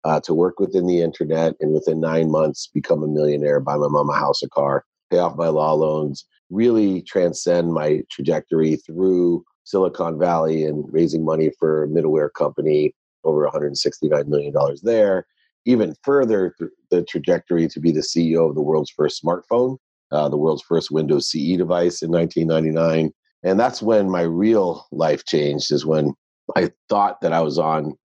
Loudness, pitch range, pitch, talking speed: -20 LUFS, 75-85 Hz, 80 Hz, 170 wpm